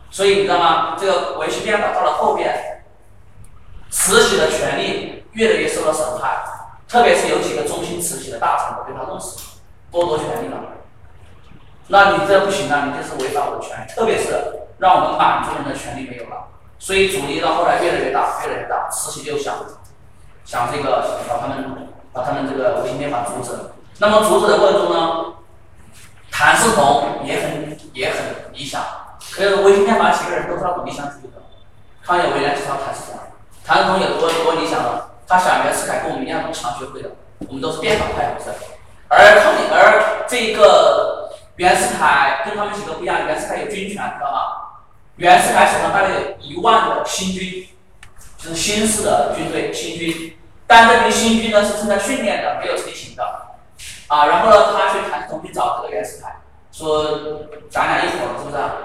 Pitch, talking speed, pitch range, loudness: 185 Hz, 290 characters per minute, 150-210 Hz, -16 LUFS